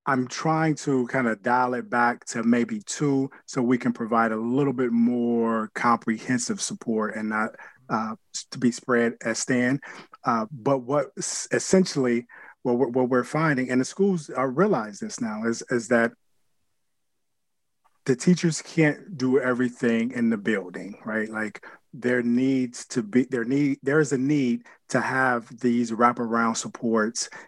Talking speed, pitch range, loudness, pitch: 155 wpm, 120-140 Hz, -25 LUFS, 125 Hz